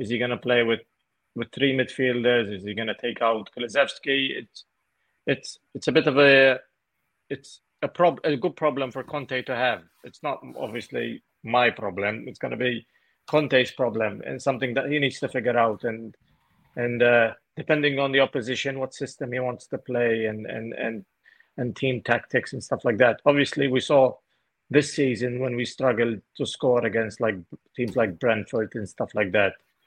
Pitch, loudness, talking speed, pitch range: 125 Hz, -24 LUFS, 185 wpm, 115-135 Hz